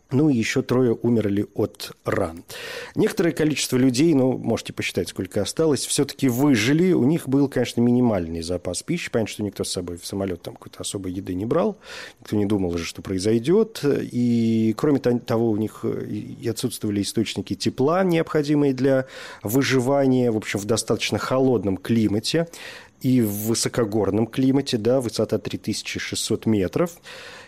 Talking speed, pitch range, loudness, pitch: 150 wpm, 105-135 Hz, -22 LUFS, 115 Hz